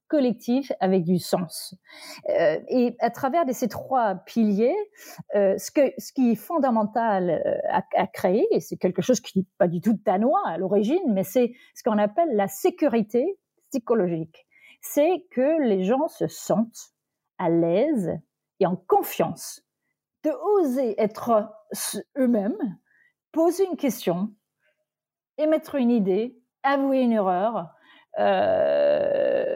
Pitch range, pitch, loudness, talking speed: 205-305 Hz, 245 Hz, -24 LUFS, 135 wpm